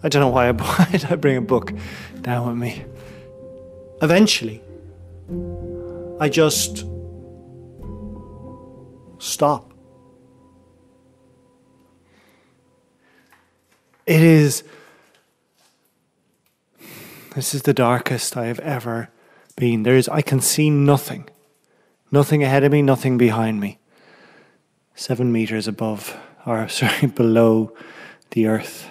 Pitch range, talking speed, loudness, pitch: 105-140 Hz, 95 wpm, -19 LUFS, 120 Hz